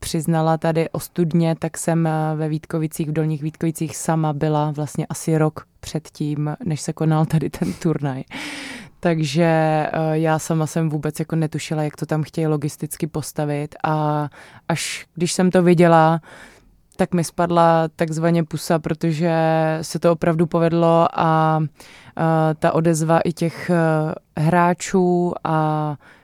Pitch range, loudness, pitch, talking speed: 155-170 Hz, -20 LUFS, 160 Hz, 135 wpm